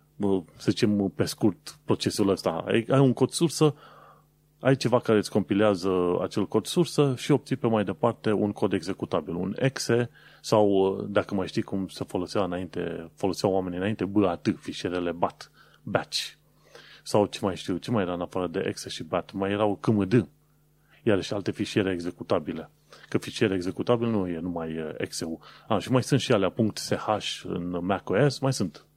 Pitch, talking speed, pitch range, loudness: 105 Hz, 170 wpm, 95-125 Hz, -27 LUFS